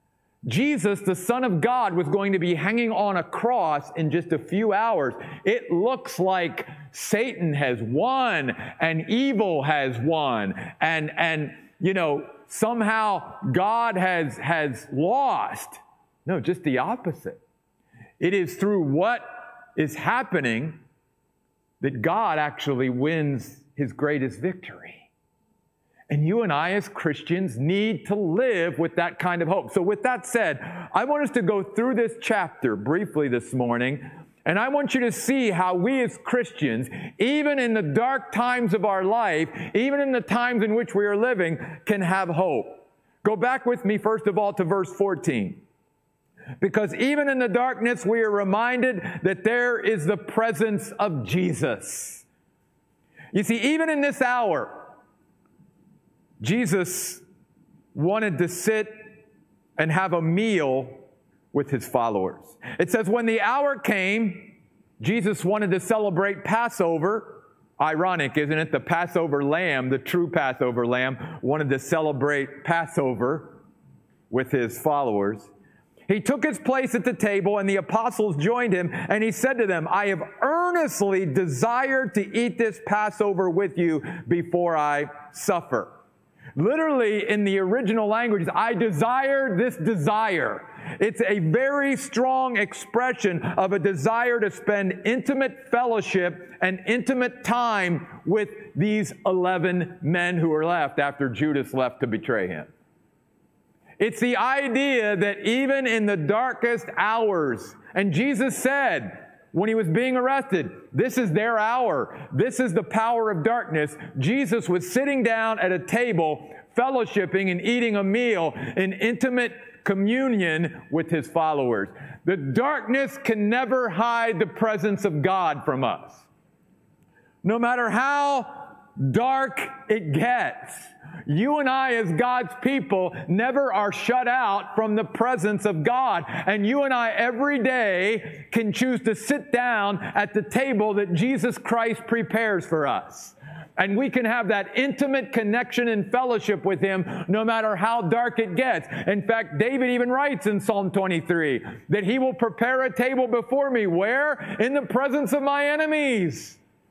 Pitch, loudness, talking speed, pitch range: 205 Hz, -24 LUFS, 150 wpm, 170-240 Hz